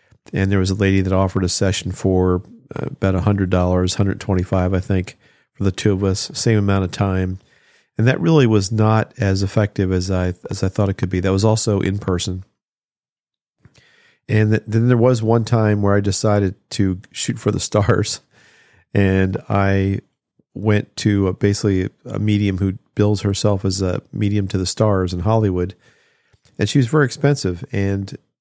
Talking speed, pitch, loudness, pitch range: 180 wpm, 100 Hz, -19 LUFS, 95-110 Hz